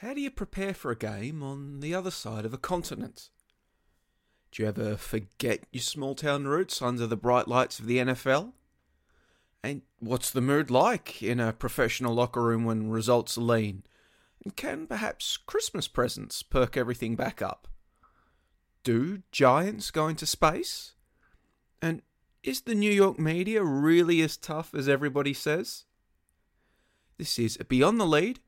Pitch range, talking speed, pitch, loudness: 115-160 Hz, 155 wpm, 130 Hz, -28 LUFS